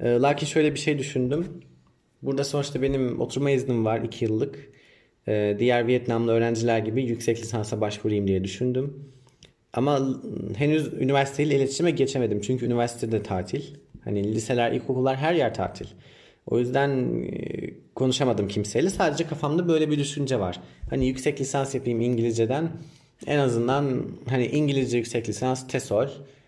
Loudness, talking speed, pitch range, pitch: -25 LUFS, 130 wpm, 115-140 Hz, 130 Hz